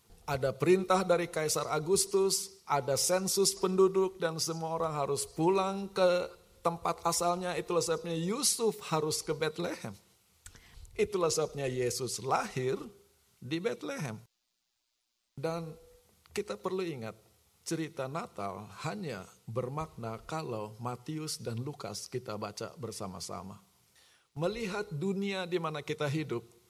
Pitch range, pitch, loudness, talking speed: 130-185 Hz, 160 Hz, -33 LUFS, 110 wpm